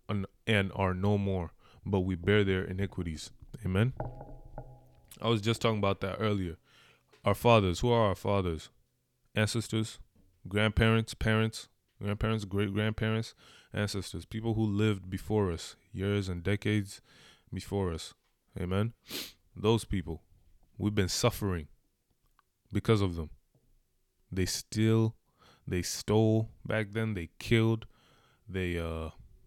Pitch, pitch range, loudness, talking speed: 105 Hz, 95-110 Hz, -31 LUFS, 120 wpm